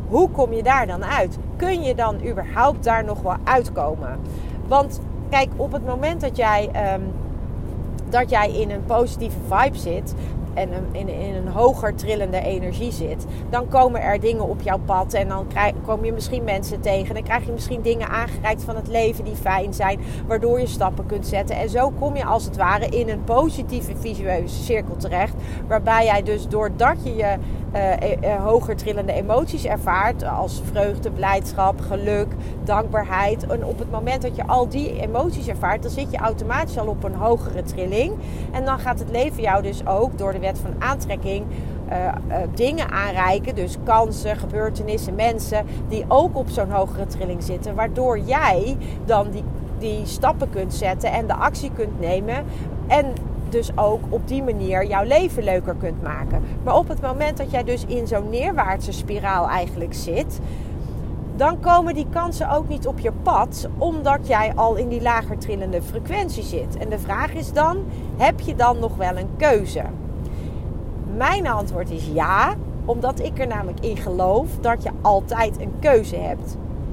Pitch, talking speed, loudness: 225 Hz, 180 wpm, -22 LUFS